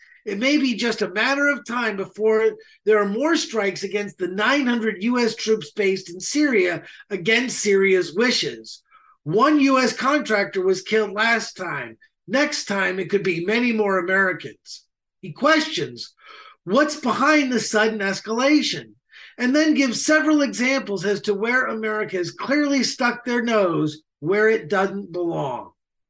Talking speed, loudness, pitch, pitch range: 145 wpm, -21 LUFS, 220 Hz, 195-275 Hz